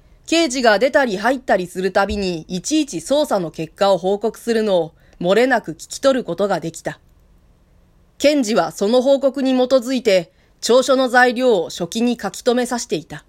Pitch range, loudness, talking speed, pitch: 190-265 Hz, -18 LUFS, 340 characters per minute, 235 Hz